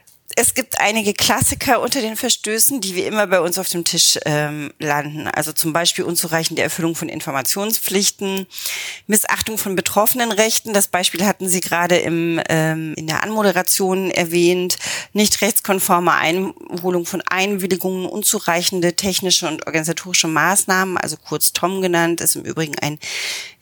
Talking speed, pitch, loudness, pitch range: 145 wpm, 180 Hz, -17 LUFS, 165-200 Hz